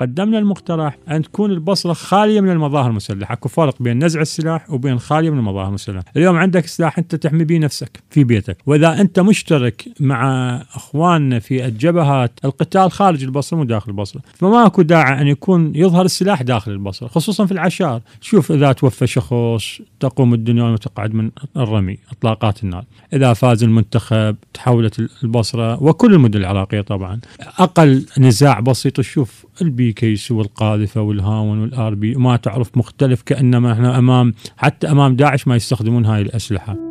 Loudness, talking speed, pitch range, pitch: -15 LUFS, 155 wpm, 115-160 Hz, 130 Hz